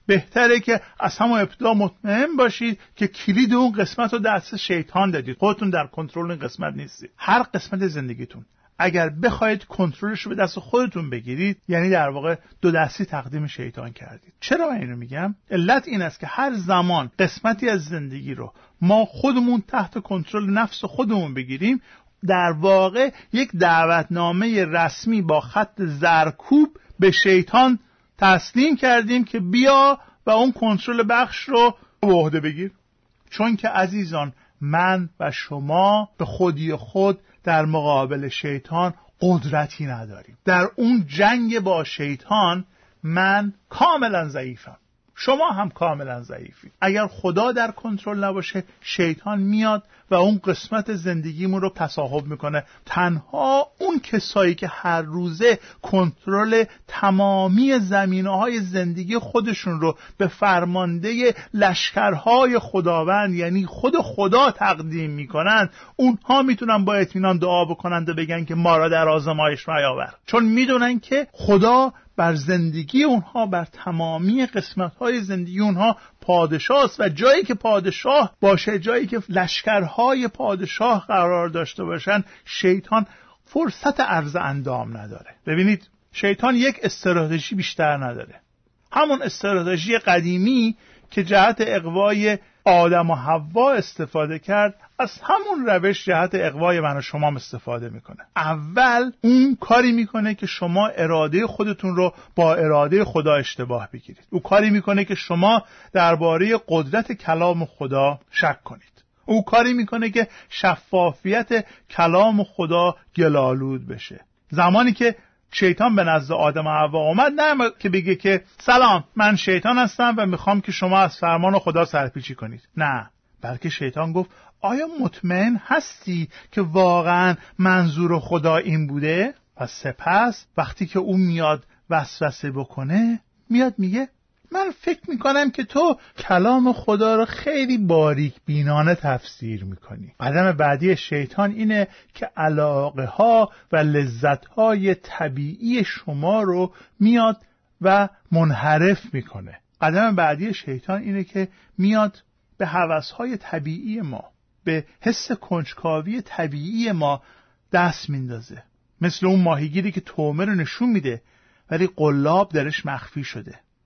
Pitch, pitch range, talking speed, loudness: 190 Hz, 160-220 Hz, 135 wpm, -20 LUFS